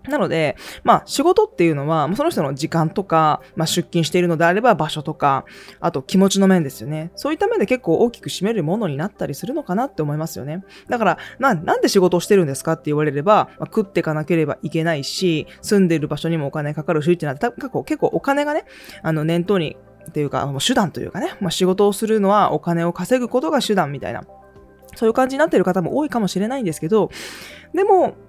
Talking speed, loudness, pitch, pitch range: 470 characters per minute, -19 LUFS, 175 Hz, 155-210 Hz